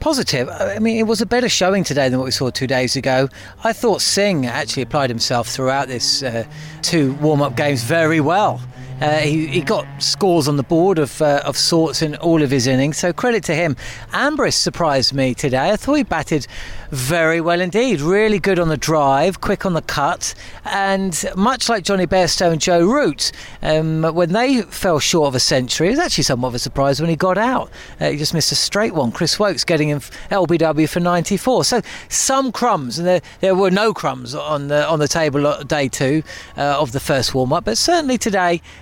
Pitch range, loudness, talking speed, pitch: 140-190 Hz, -17 LUFS, 210 wpm, 155 Hz